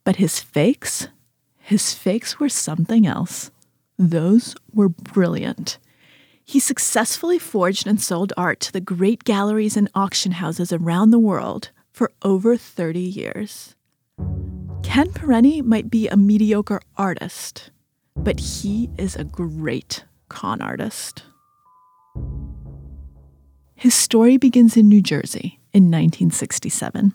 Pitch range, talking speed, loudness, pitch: 170-225 Hz, 115 wpm, -19 LUFS, 200 Hz